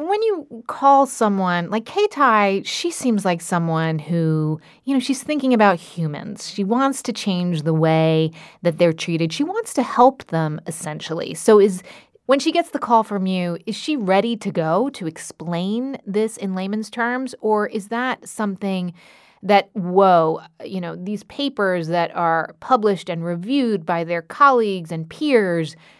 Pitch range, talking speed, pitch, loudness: 170-245 Hz, 165 wpm, 195 Hz, -20 LUFS